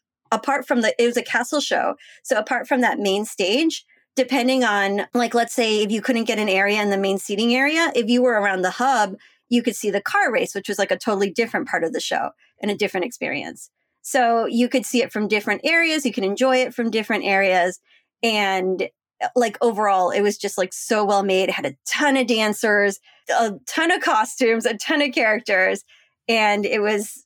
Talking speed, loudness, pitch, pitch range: 215 wpm, -20 LUFS, 225 Hz, 205-255 Hz